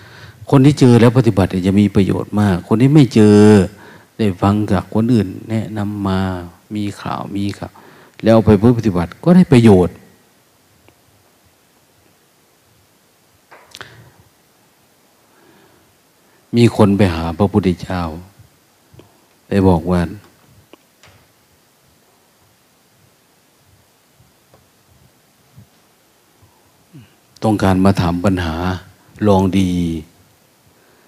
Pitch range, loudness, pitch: 90-110 Hz, -14 LUFS, 100 Hz